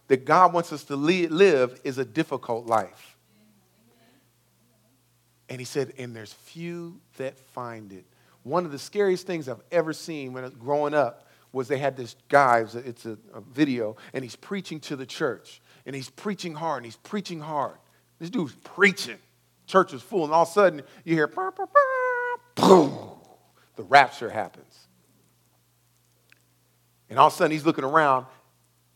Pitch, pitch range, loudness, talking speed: 135 Hz, 115-165 Hz, -24 LUFS, 175 wpm